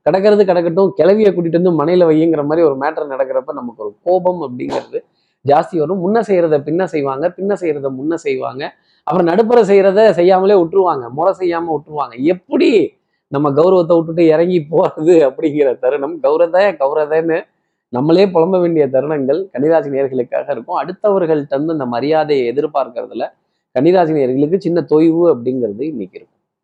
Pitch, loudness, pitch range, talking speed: 170 Hz, -14 LUFS, 155-195 Hz, 135 wpm